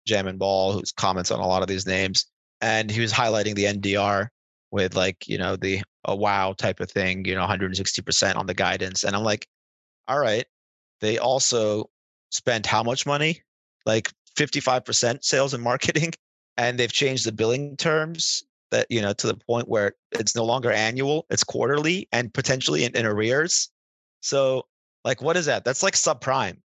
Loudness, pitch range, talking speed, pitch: -23 LUFS, 95-130 Hz, 185 wpm, 110 Hz